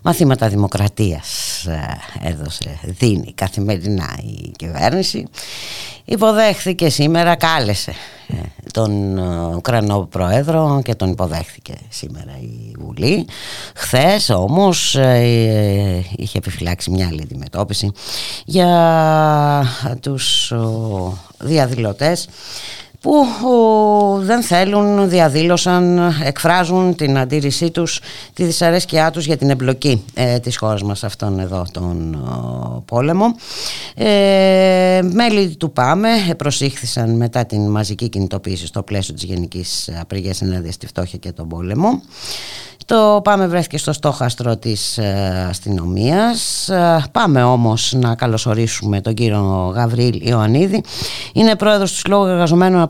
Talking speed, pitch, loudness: 100 wpm, 120 Hz, -16 LUFS